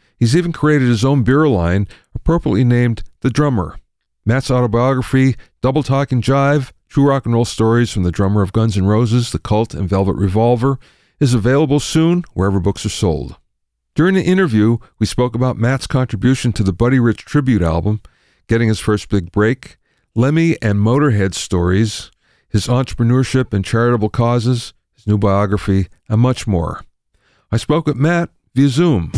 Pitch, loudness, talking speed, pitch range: 120 Hz, -16 LUFS, 165 wpm, 105-135 Hz